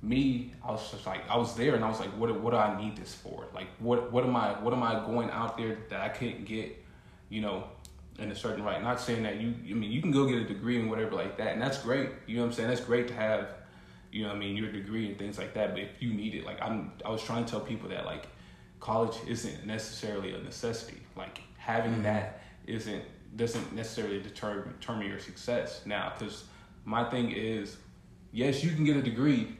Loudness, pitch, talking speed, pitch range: -33 LUFS, 110 Hz, 245 wpm, 105-120 Hz